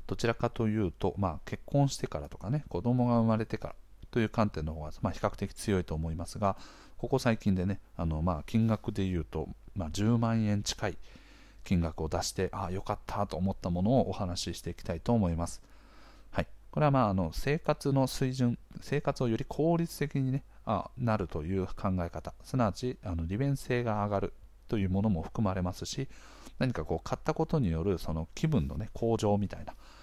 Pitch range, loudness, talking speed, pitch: 90-120 Hz, -32 LUFS, 370 characters per minute, 100 Hz